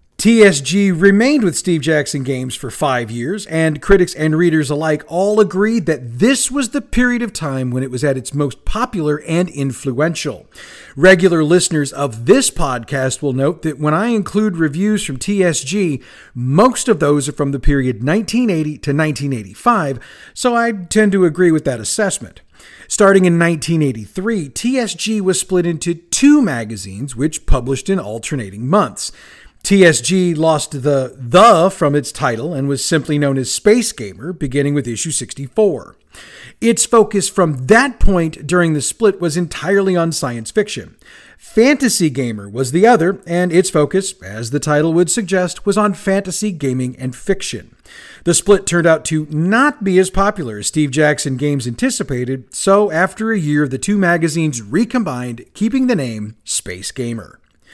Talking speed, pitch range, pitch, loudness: 160 wpm, 140-195 Hz, 160 Hz, -15 LUFS